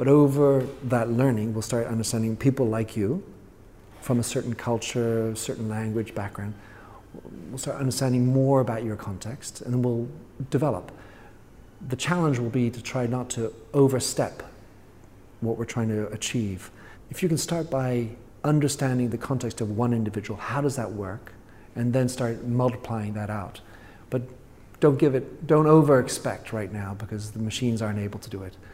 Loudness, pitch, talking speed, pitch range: -26 LUFS, 115 Hz, 165 wpm, 110-130 Hz